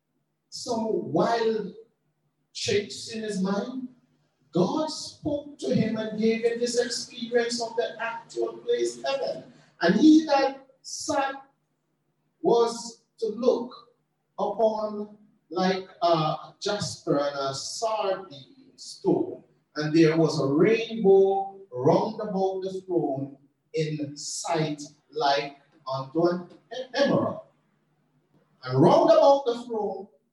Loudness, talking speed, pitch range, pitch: -26 LUFS, 110 wpm, 160-235 Hz, 205 Hz